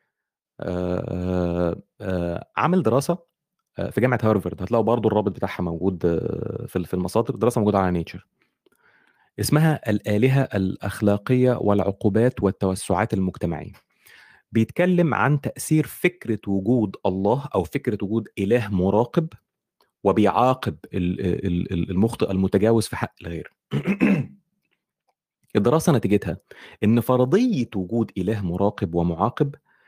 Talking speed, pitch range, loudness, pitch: 95 wpm, 95-125 Hz, -23 LUFS, 105 Hz